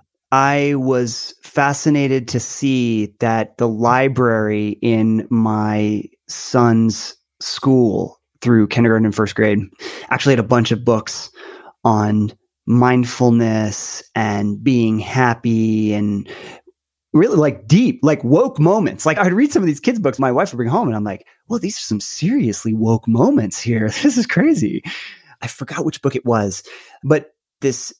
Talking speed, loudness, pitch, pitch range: 150 wpm, -17 LUFS, 120 Hz, 110-140 Hz